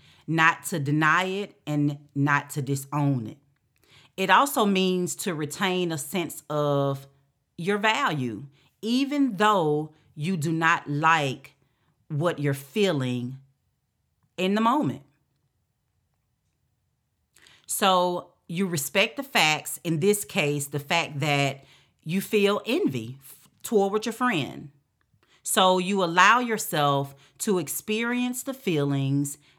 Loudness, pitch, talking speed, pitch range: -25 LUFS, 155 Hz, 115 wpm, 140-190 Hz